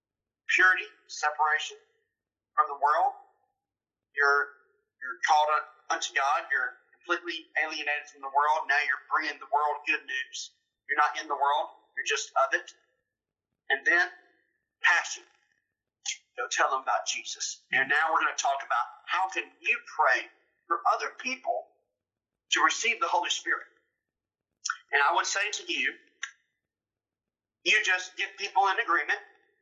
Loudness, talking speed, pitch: -27 LUFS, 145 wpm, 340 Hz